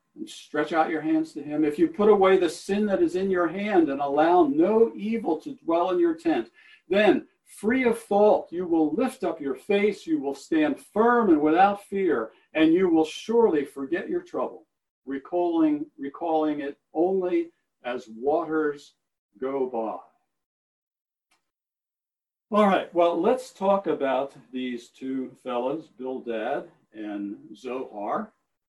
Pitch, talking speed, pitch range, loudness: 170 Hz, 150 wpm, 145-210 Hz, -25 LUFS